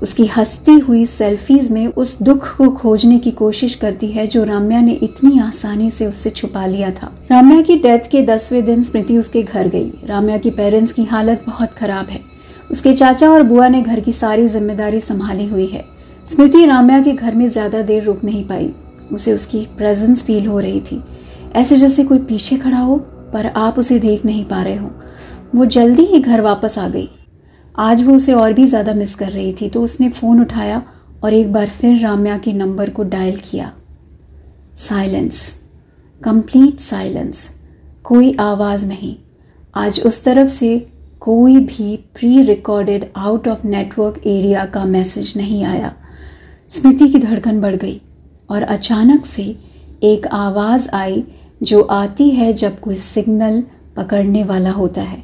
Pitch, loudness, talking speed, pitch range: 220 Hz, -13 LUFS, 175 wpm, 205-245 Hz